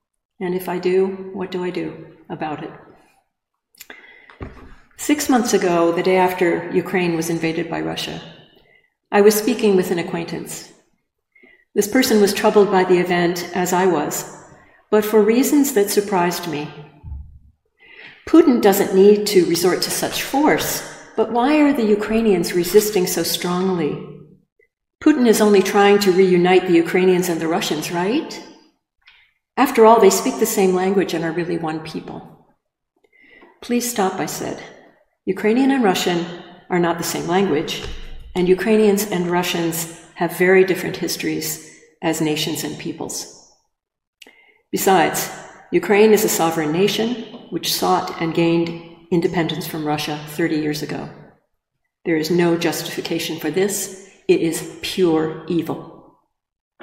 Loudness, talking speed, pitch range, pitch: -18 LUFS, 140 wpm, 170-210 Hz, 185 Hz